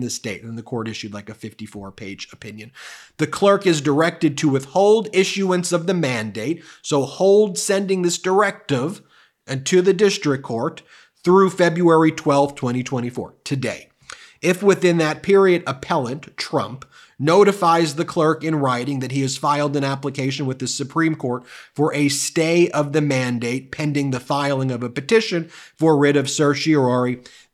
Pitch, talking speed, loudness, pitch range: 150 Hz, 160 wpm, -19 LUFS, 130-175 Hz